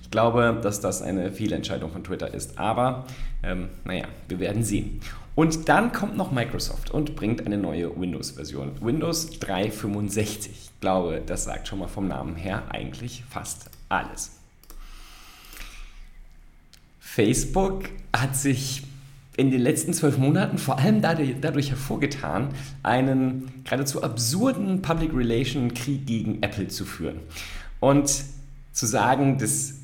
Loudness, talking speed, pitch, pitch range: -26 LUFS, 130 wpm, 125 Hz, 100-140 Hz